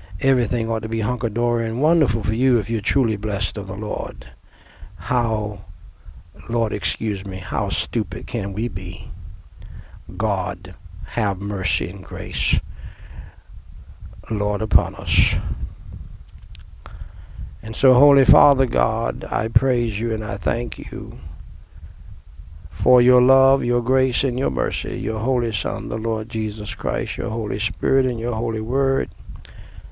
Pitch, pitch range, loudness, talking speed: 100 Hz, 90-115 Hz, -21 LUFS, 135 wpm